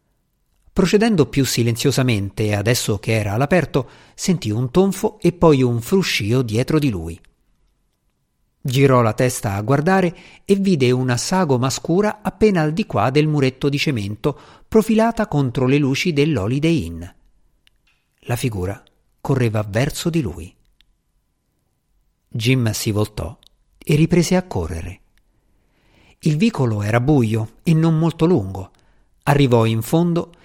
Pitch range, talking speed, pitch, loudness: 115-165 Hz, 130 wpm, 135 Hz, -18 LUFS